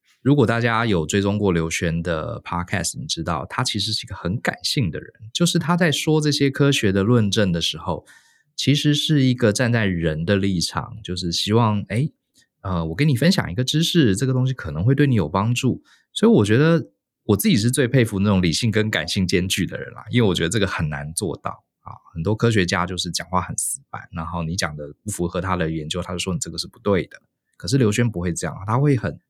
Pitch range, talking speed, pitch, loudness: 90-130 Hz, 340 characters per minute, 105 Hz, -21 LUFS